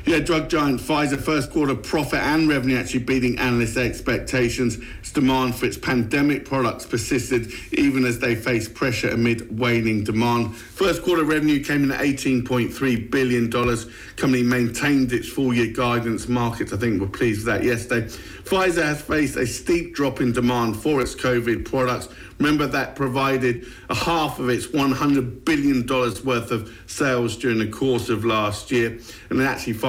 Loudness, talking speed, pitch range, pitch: -22 LUFS, 165 wpm, 120-140 Hz, 125 Hz